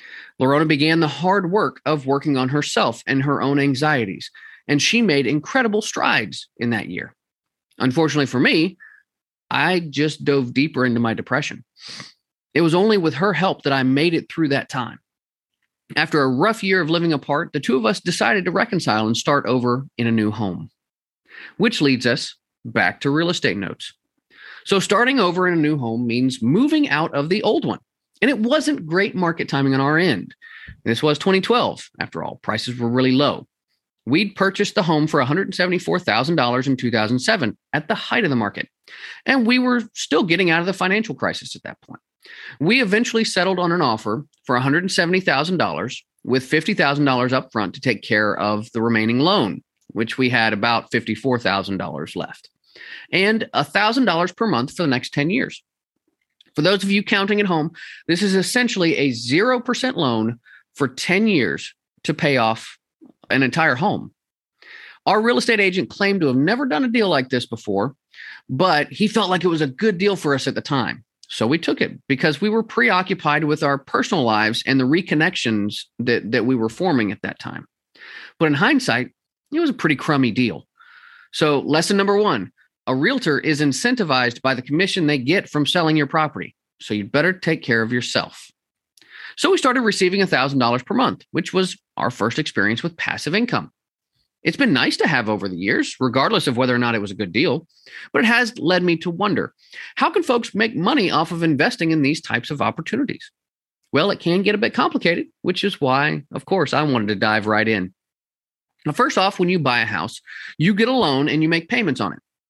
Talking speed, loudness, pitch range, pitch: 195 wpm, -19 LUFS, 125-195 Hz, 155 Hz